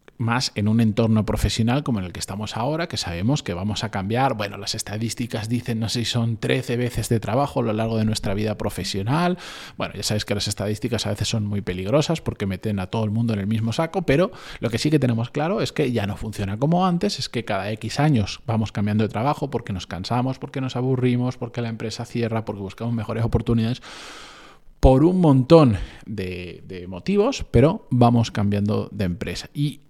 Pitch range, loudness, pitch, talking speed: 105-130 Hz, -23 LUFS, 115 Hz, 215 wpm